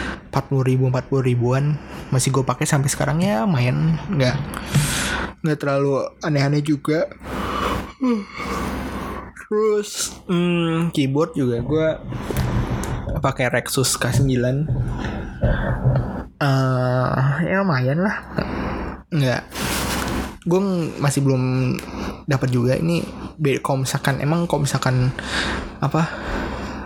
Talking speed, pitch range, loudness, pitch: 95 wpm, 125-155 Hz, -21 LUFS, 135 Hz